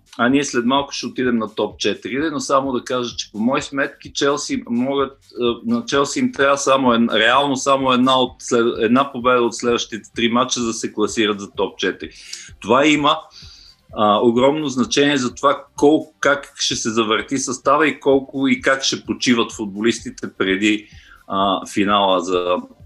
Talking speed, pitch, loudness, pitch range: 170 wpm, 125 Hz, -18 LUFS, 115-140 Hz